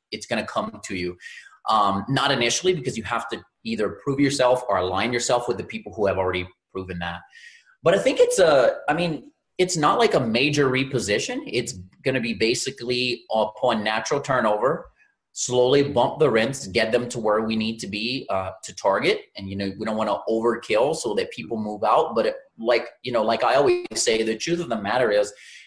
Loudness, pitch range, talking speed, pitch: -23 LUFS, 110-180 Hz, 215 wpm, 120 Hz